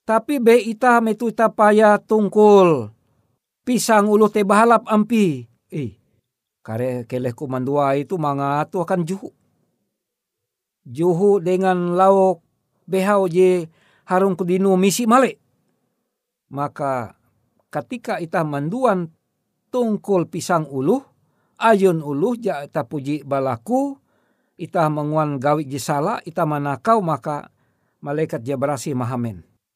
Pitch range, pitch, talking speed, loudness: 140-210 Hz, 175 Hz, 105 wpm, -19 LUFS